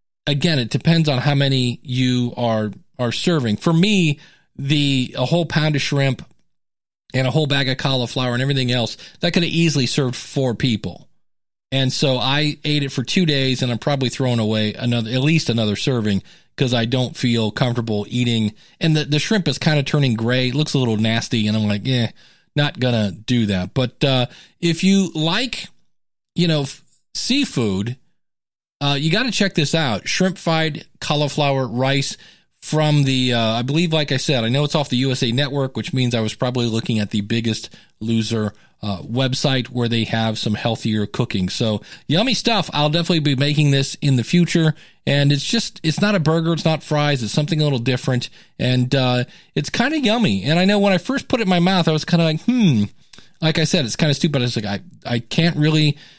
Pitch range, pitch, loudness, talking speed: 120-160 Hz, 135 Hz, -19 LUFS, 205 wpm